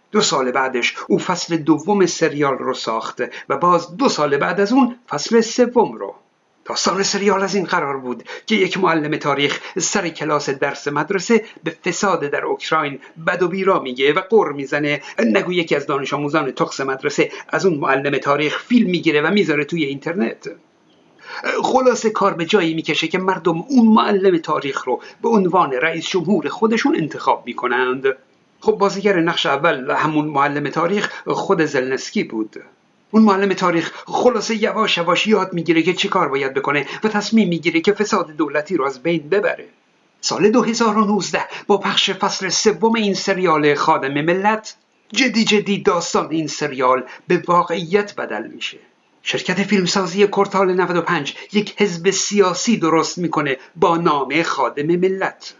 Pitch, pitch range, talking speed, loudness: 180 Hz, 155-205 Hz, 155 wpm, -18 LUFS